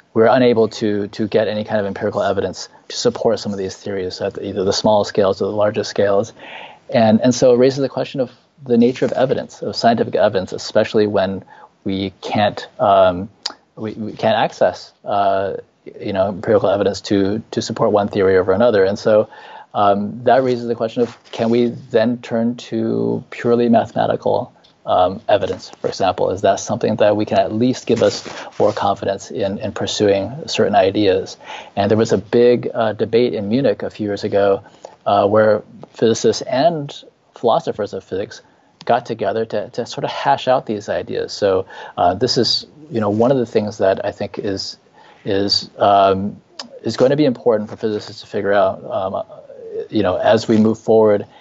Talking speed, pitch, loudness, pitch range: 190 wpm, 110 Hz, -17 LUFS, 100-120 Hz